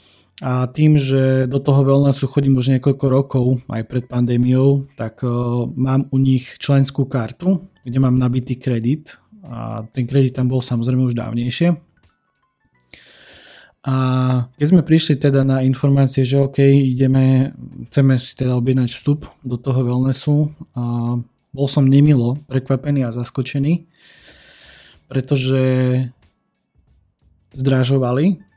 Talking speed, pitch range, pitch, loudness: 120 wpm, 125-140 Hz, 130 Hz, -17 LUFS